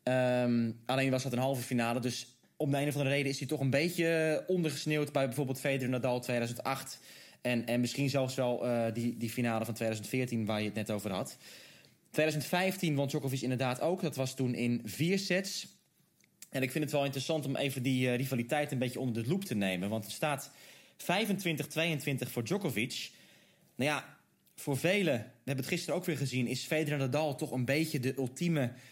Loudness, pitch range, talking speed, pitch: -33 LUFS, 125-150 Hz, 200 wpm, 135 Hz